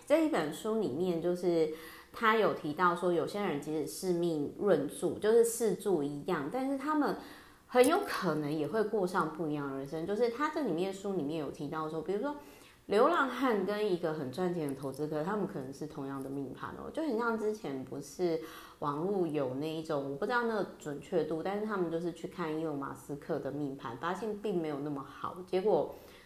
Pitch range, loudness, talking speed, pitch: 150-205 Hz, -34 LUFS, 310 characters per minute, 170 Hz